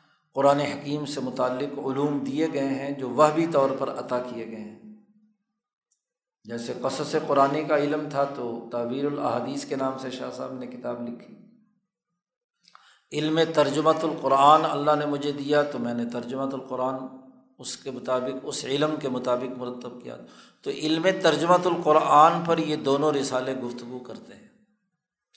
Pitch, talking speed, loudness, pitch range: 145 Hz, 155 wpm, -25 LUFS, 130-160 Hz